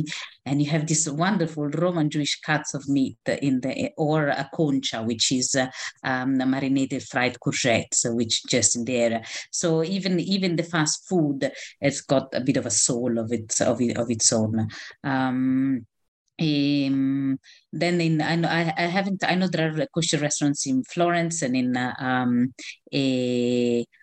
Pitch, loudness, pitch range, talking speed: 135 Hz, -24 LUFS, 125-155 Hz, 170 wpm